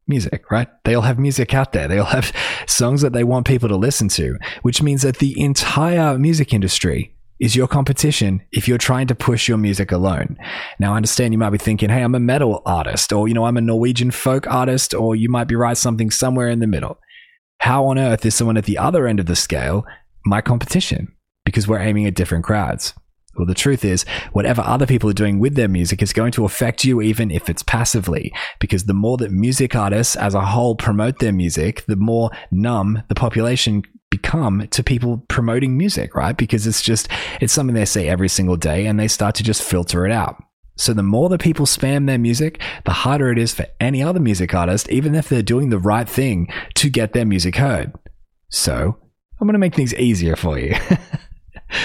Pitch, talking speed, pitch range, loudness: 115 Hz, 215 wpm, 100-130 Hz, -17 LUFS